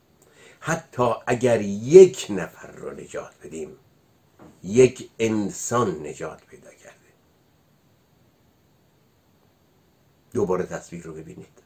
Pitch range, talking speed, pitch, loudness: 105-130 Hz, 80 wpm, 120 Hz, -21 LUFS